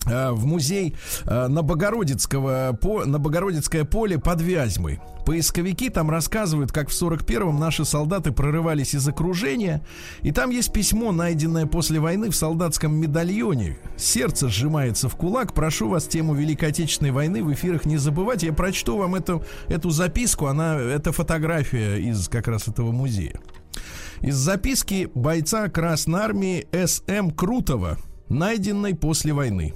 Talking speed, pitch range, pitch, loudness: 135 wpm, 140-180 Hz, 160 Hz, -23 LUFS